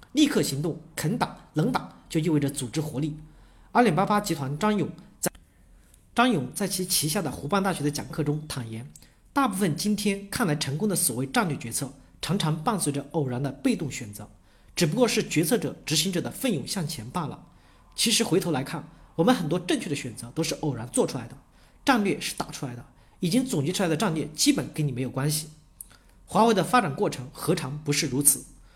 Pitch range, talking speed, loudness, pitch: 140-195 Hz, 305 characters per minute, -26 LUFS, 155 Hz